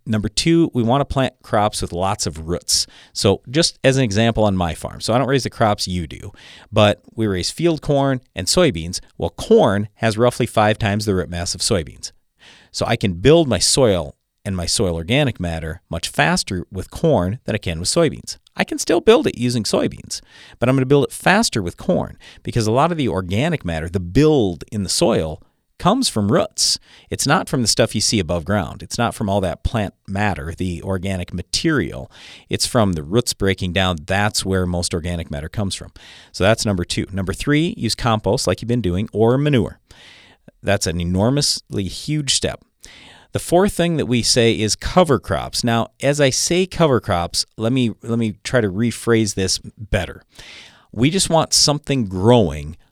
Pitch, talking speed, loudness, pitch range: 105 Hz, 200 wpm, -18 LUFS, 90-125 Hz